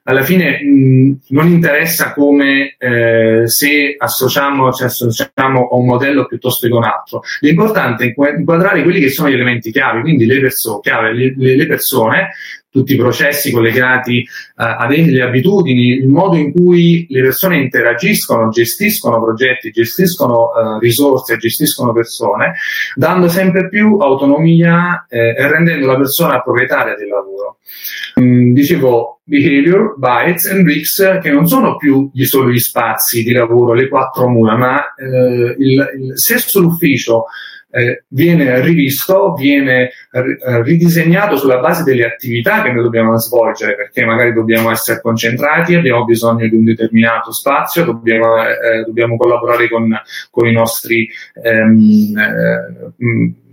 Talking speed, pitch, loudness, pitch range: 145 wpm, 130 Hz, -11 LUFS, 115-155 Hz